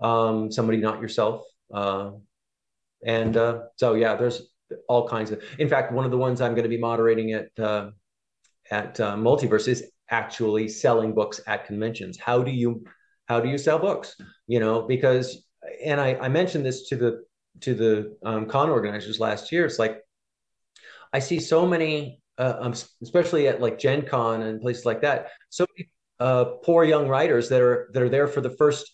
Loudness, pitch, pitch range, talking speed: -24 LUFS, 120 Hz, 110-135 Hz, 190 wpm